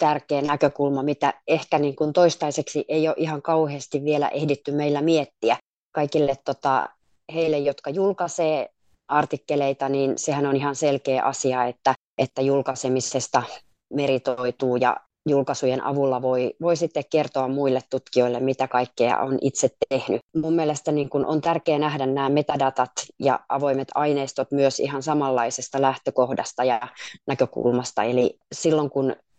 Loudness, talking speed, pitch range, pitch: -23 LUFS, 135 wpm, 135-150 Hz, 140 Hz